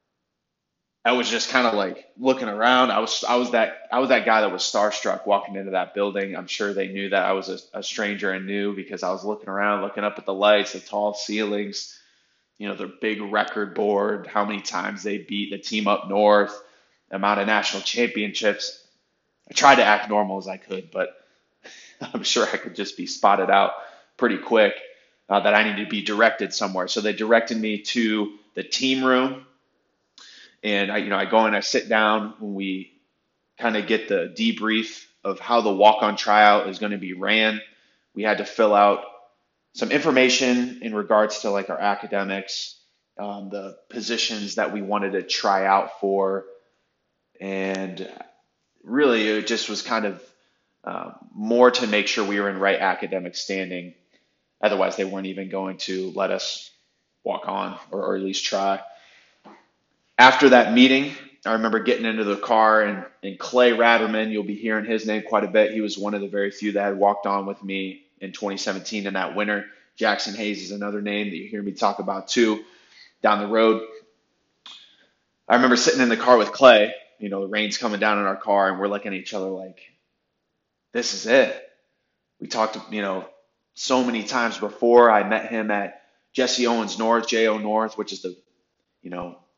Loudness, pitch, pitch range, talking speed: -22 LUFS, 105 Hz, 100-110 Hz, 195 wpm